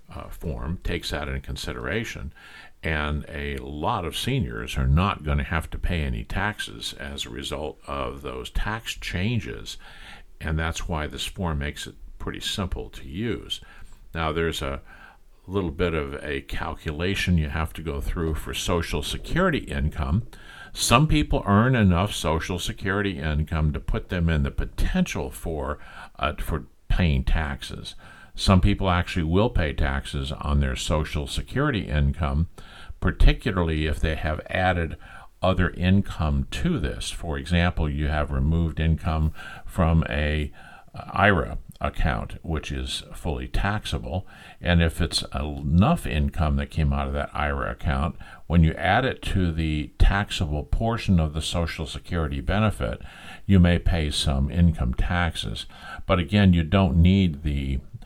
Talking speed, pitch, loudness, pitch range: 150 wpm, 80 Hz, -25 LUFS, 75-90 Hz